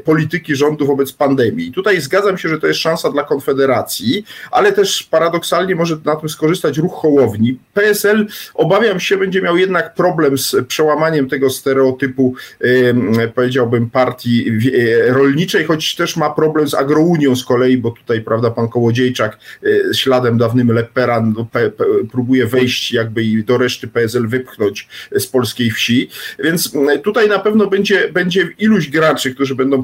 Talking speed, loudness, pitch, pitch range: 150 wpm, -14 LUFS, 140 Hz, 125-170 Hz